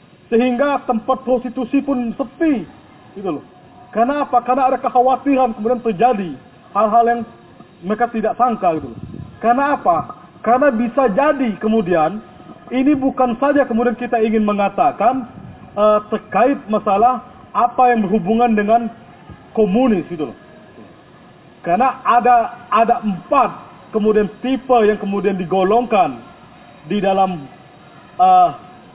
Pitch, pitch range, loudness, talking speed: 240 Hz, 215-255 Hz, -17 LUFS, 115 wpm